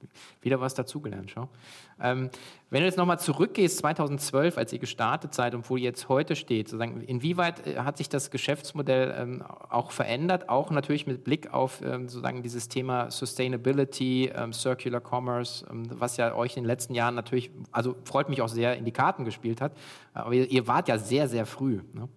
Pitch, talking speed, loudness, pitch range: 130 Hz, 190 wpm, -29 LUFS, 120-140 Hz